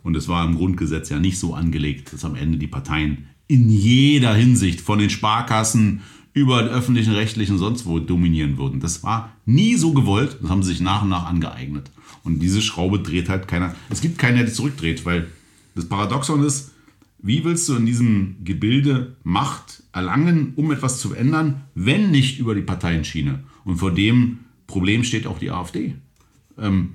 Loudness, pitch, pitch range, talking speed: -20 LUFS, 105 Hz, 85-125 Hz, 185 wpm